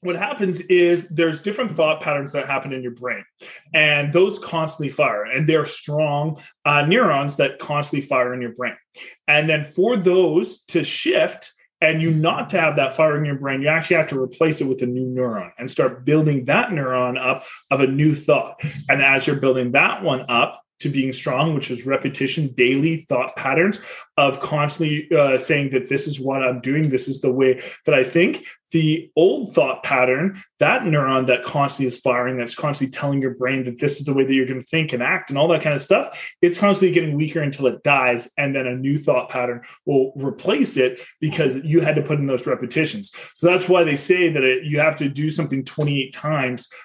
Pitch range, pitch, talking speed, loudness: 130-160 Hz, 145 Hz, 215 wpm, -19 LUFS